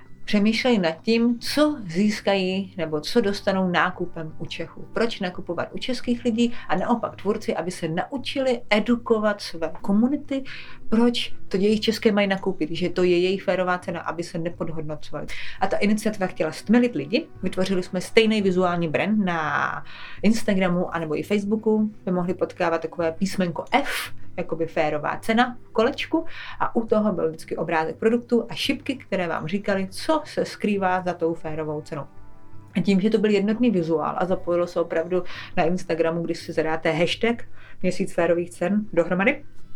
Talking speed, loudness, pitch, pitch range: 160 wpm, -24 LUFS, 185 Hz, 170-220 Hz